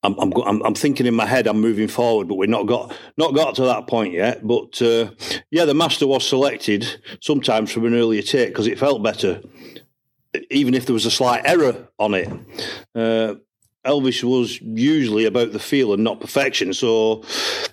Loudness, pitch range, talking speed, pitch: -19 LUFS, 110-140 Hz, 190 wpm, 120 Hz